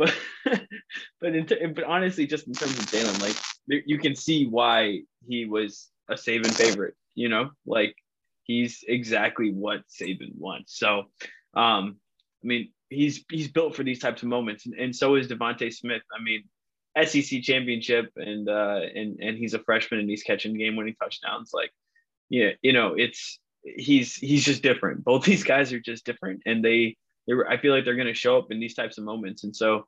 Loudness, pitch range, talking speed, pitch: -25 LUFS, 110-145 Hz, 195 wpm, 120 Hz